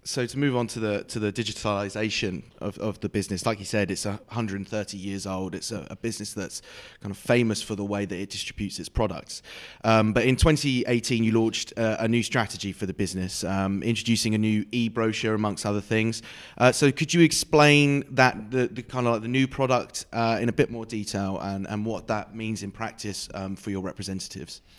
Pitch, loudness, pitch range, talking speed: 110 Hz, -26 LUFS, 100-120 Hz, 215 wpm